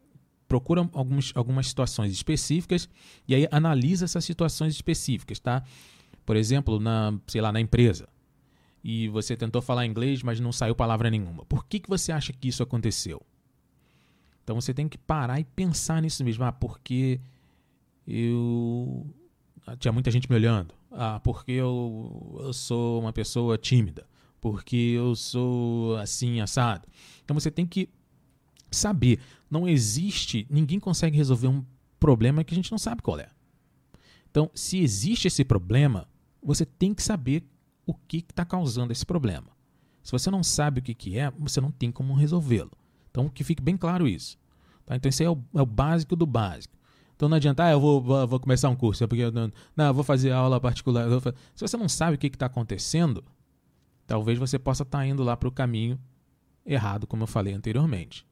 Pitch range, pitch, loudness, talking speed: 115-150 Hz, 130 Hz, -26 LUFS, 180 wpm